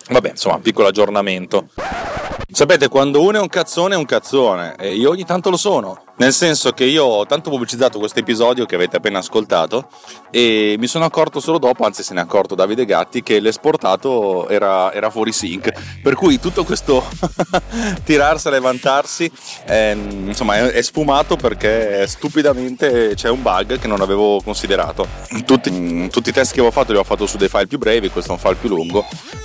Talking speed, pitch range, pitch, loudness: 190 wpm, 105-150 Hz, 125 Hz, -16 LUFS